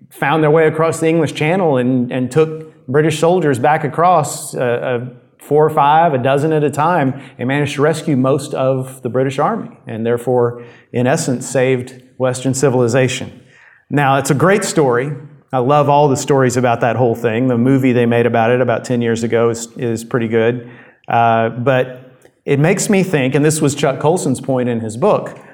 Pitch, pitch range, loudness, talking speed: 130 Hz, 125-150 Hz, -15 LUFS, 195 wpm